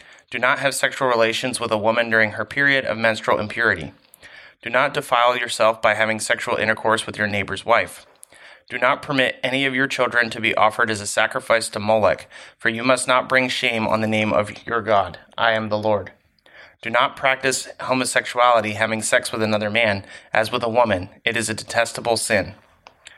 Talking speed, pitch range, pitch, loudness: 195 wpm, 110-125 Hz, 115 Hz, -20 LUFS